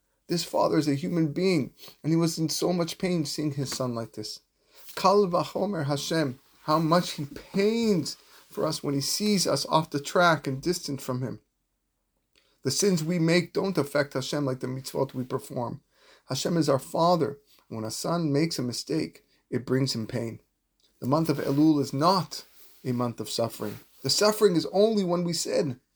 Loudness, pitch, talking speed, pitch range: -27 LUFS, 150 Hz, 185 wpm, 130-175 Hz